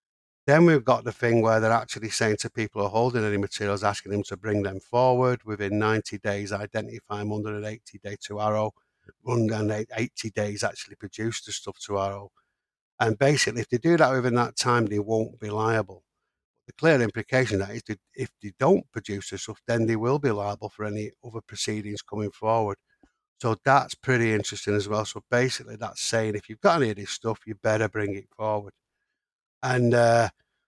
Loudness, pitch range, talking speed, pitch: -26 LUFS, 105-115 Hz, 205 wpm, 110 Hz